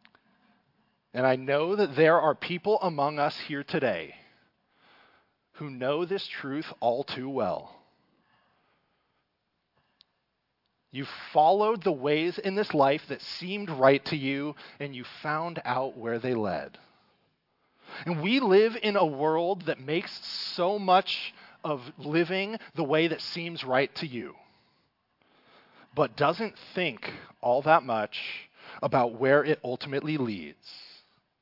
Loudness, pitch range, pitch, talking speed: -28 LUFS, 135-180 Hz, 155 Hz, 130 wpm